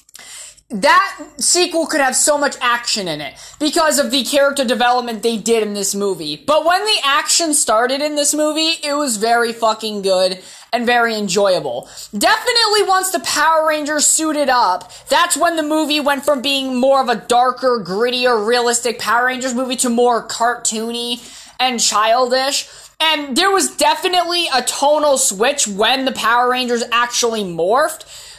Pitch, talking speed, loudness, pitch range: 260 Hz, 160 wpm, -15 LUFS, 235-300 Hz